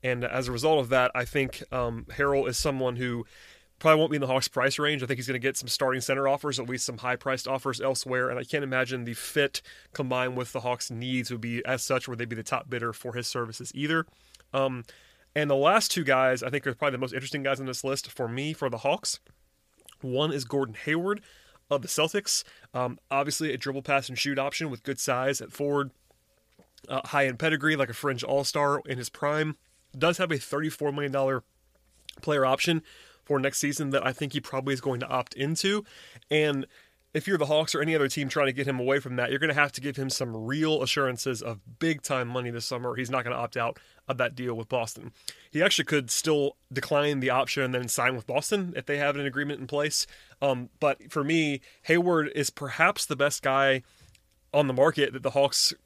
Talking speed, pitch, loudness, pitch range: 230 wpm, 135 Hz, -28 LUFS, 125-145 Hz